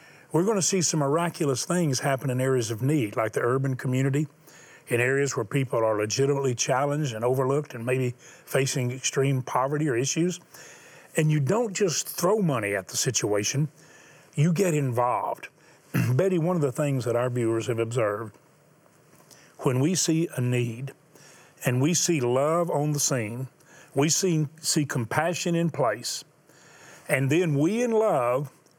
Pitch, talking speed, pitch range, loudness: 140 Hz, 160 wpm, 125-160 Hz, -25 LUFS